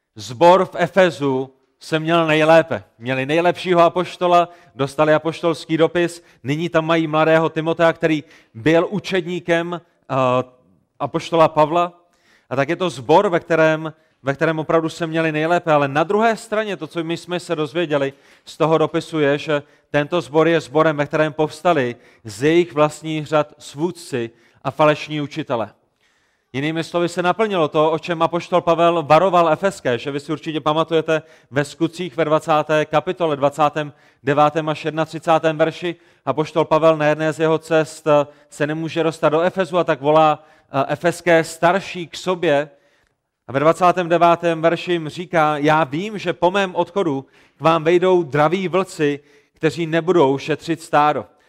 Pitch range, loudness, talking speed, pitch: 150-170 Hz, -18 LUFS, 150 wpm, 160 Hz